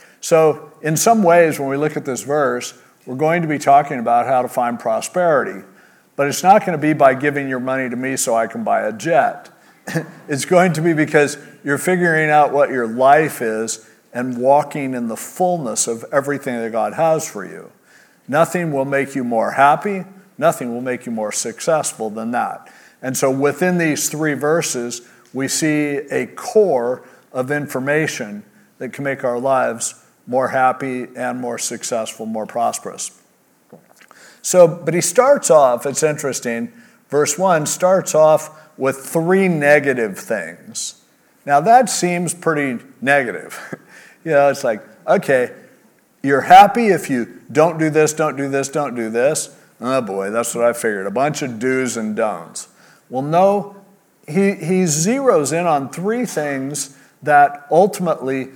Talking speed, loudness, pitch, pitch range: 165 wpm, -17 LUFS, 145 Hz, 130-170 Hz